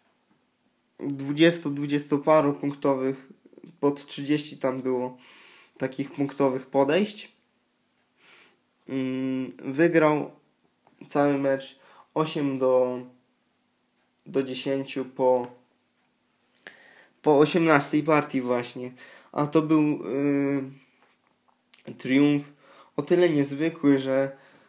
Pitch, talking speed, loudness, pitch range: 140 Hz, 75 wpm, -25 LUFS, 130-150 Hz